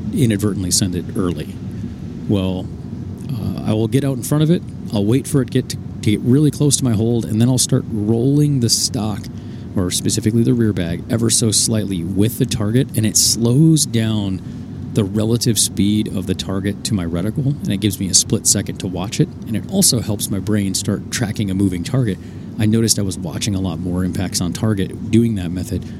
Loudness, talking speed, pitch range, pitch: -17 LUFS, 215 wpm, 100-120 Hz, 110 Hz